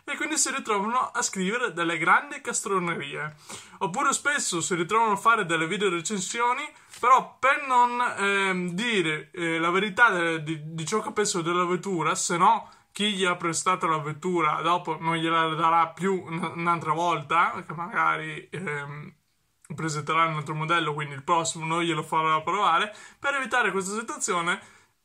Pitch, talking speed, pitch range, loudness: 175 Hz, 160 wpm, 165-215 Hz, -25 LUFS